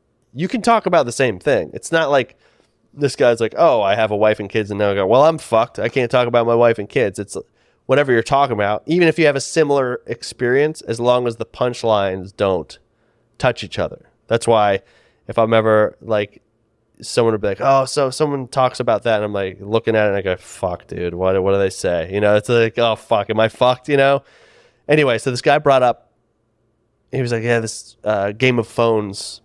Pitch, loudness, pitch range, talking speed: 115 Hz, -17 LUFS, 105-130 Hz, 230 wpm